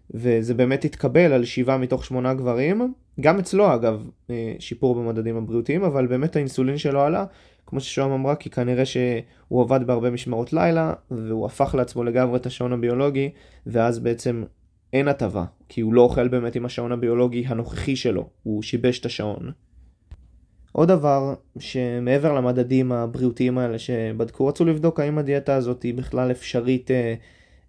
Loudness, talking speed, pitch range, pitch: -22 LUFS, 150 wpm, 115-135 Hz, 125 Hz